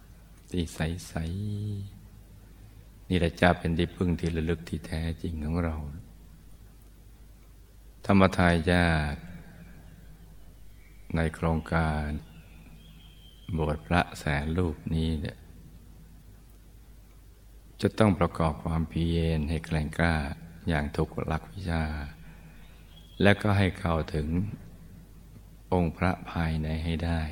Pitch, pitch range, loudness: 85 Hz, 80-95 Hz, -29 LUFS